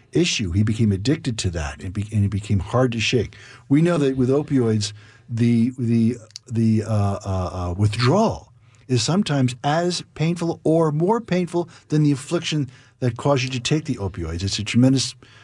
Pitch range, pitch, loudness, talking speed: 105-145 Hz, 120 Hz, -21 LUFS, 170 wpm